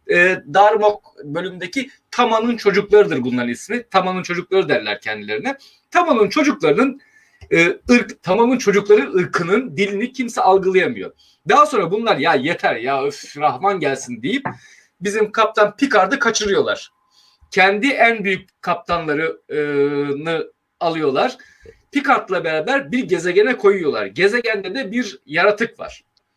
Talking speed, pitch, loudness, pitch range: 120 wpm, 210 Hz, -17 LUFS, 185-250 Hz